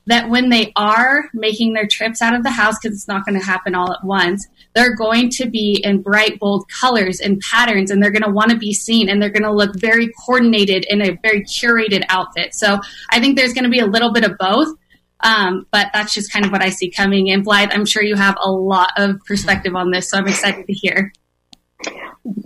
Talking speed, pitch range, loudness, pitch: 240 wpm, 195-225 Hz, -15 LUFS, 205 Hz